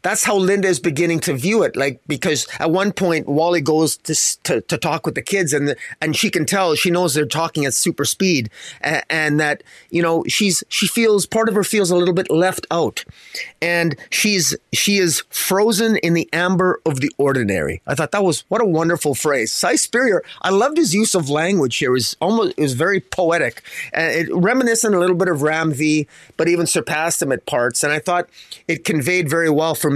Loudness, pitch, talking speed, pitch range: -17 LUFS, 170 Hz, 220 wpm, 155-190 Hz